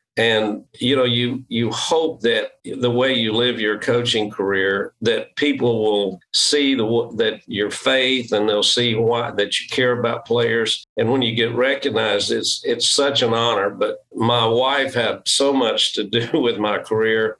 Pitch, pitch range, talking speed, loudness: 115 Hz, 110-130 Hz, 180 wpm, -19 LUFS